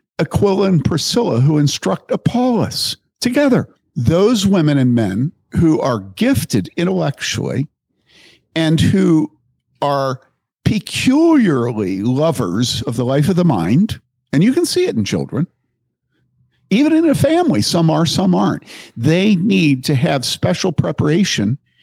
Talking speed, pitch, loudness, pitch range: 130 wpm, 160 Hz, -16 LUFS, 130-190 Hz